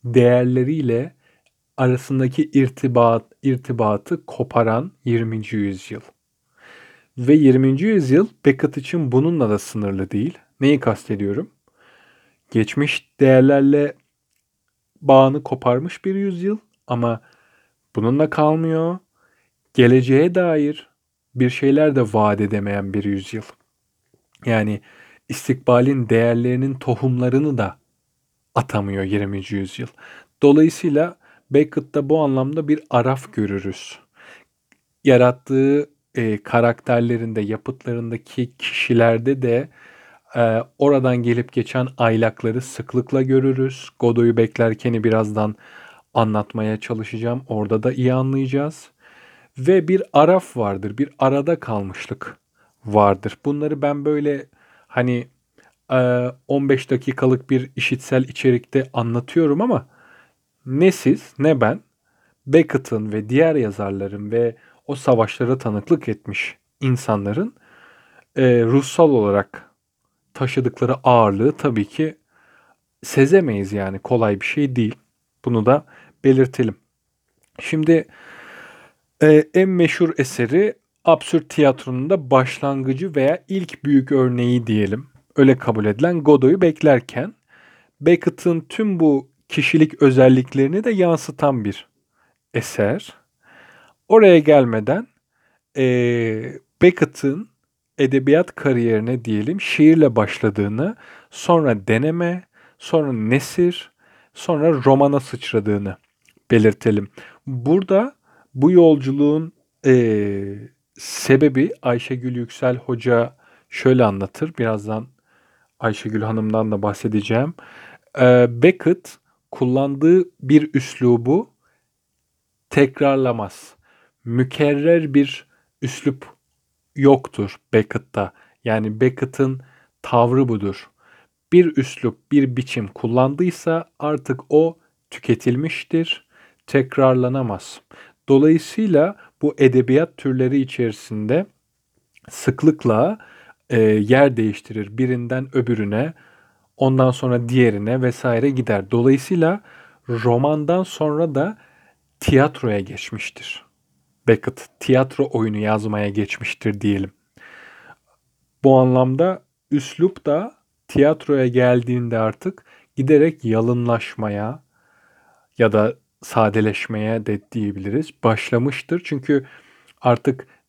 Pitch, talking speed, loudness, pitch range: 130 Hz, 85 wpm, -18 LUFS, 115-145 Hz